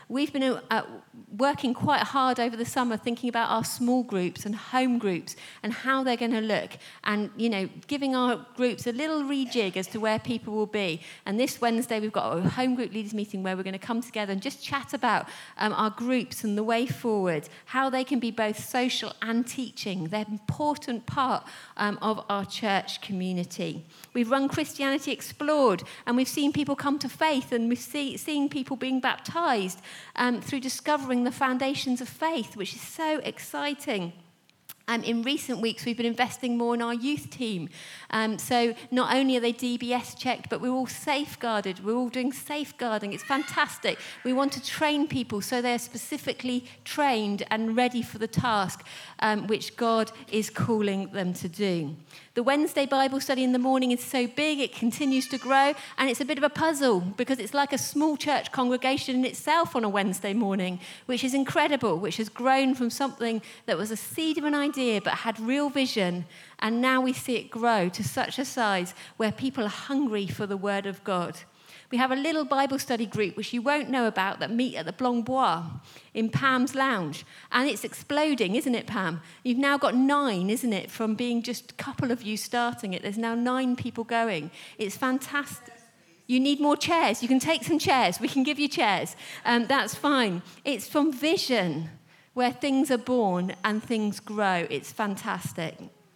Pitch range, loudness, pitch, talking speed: 210-265 Hz, -27 LUFS, 240 Hz, 195 wpm